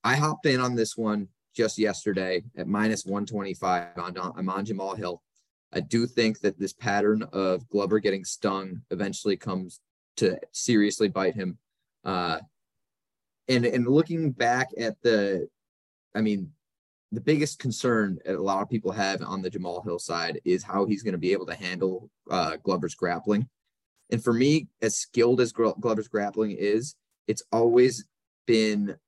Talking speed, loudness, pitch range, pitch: 160 wpm, -27 LUFS, 95-120 Hz, 110 Hz